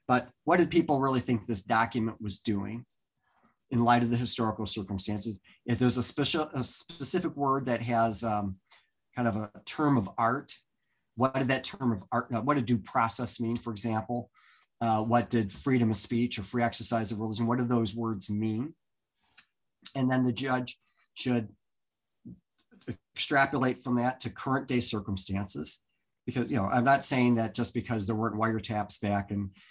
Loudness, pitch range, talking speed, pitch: -30 LUFS, 110-125 Hz, 175 wpm, 120 Hz